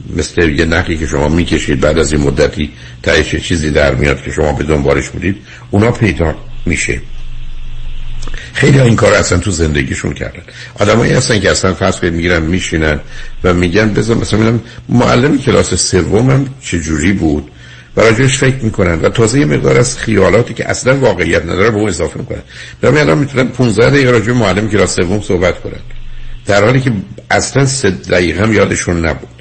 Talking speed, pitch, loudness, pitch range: 180 wpm, 95 Hz, -11 LUFS, 80-120 Hz